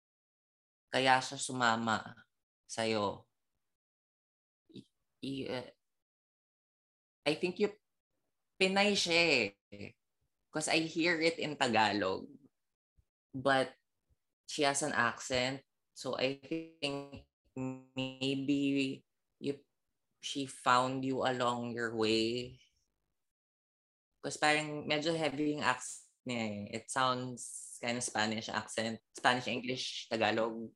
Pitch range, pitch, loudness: 110-140 Hz, 130 Hz, -34 LUFS